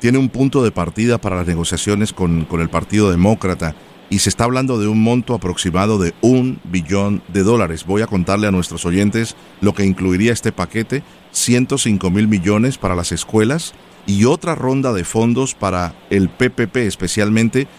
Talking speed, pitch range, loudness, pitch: 175 wpm, 90-120 Hz, -17 LUFS, 105 Hz